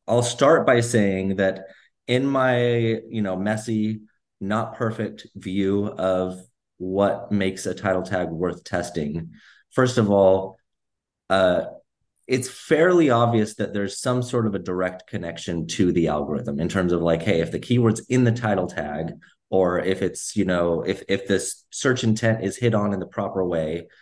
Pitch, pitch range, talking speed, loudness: 100 Hz, 95-115 Hz, 170 wpm, -23 LUFS